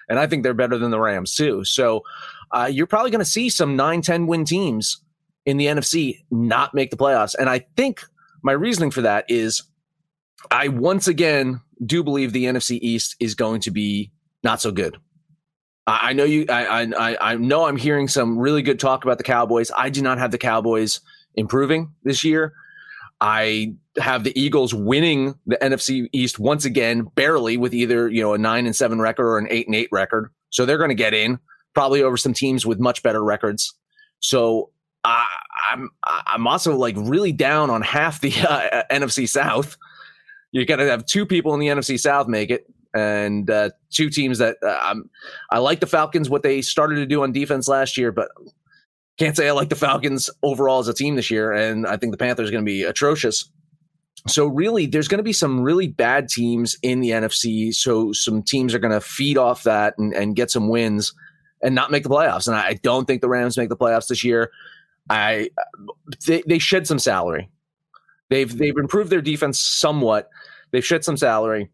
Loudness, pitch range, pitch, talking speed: -20 LUFS, 115-155 Hz, 130 Hz, 205 wpm